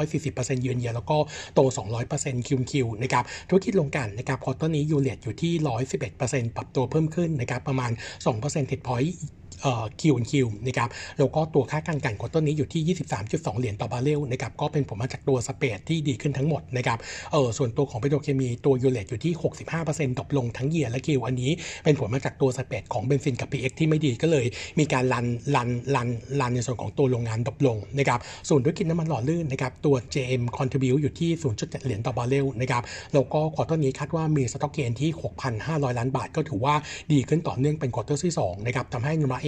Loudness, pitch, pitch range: -26 LUFS, 135 Hz, 125-150 Hz